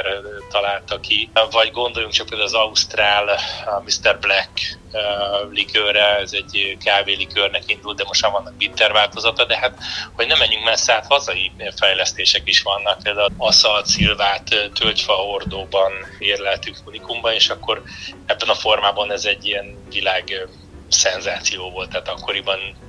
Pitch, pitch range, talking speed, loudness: 100 Hz, 95-105 Hz, 140 wpm, -17 LUFS